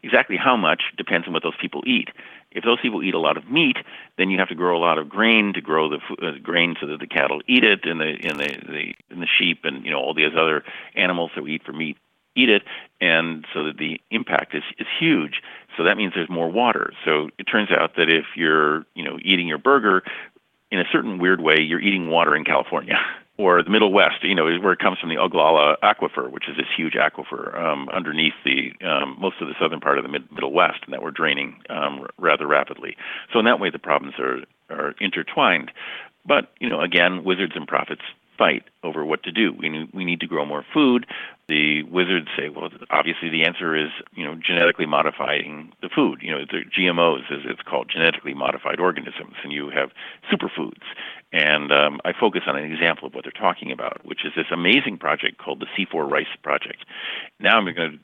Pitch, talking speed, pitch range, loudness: 85 Hz, 225 wpm, 80-90 Hz, -21 LUFS